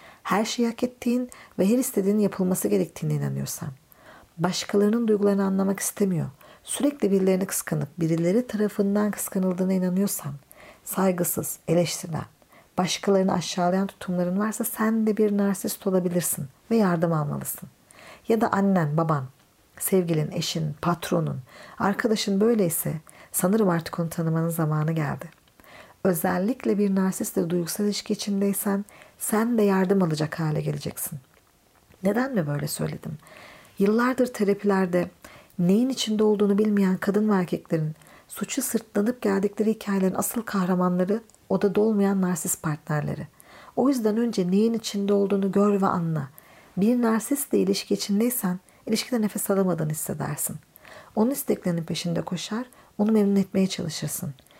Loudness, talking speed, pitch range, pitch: -25 LUFS, 120 wpm, 175-215 Hz, 195 Hz